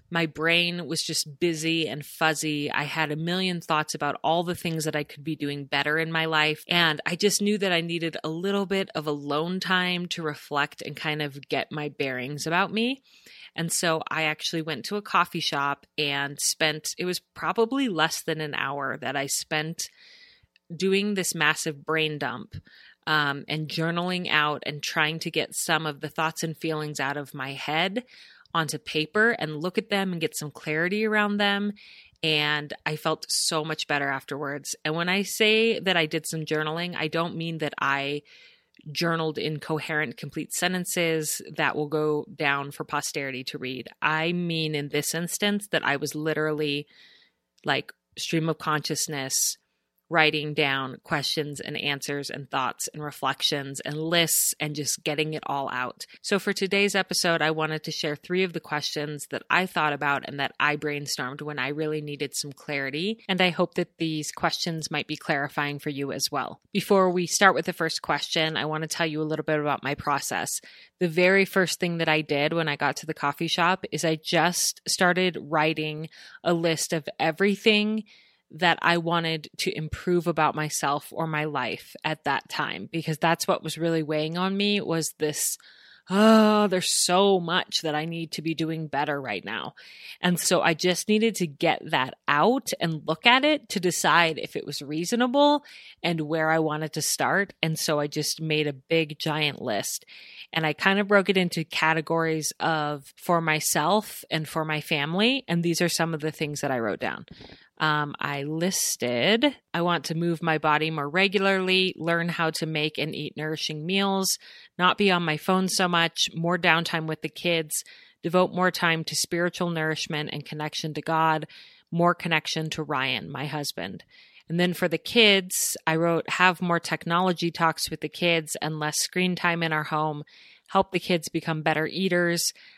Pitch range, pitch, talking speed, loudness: 150-180 Hz, 160 Hz, 190 wpm, -25 LUFS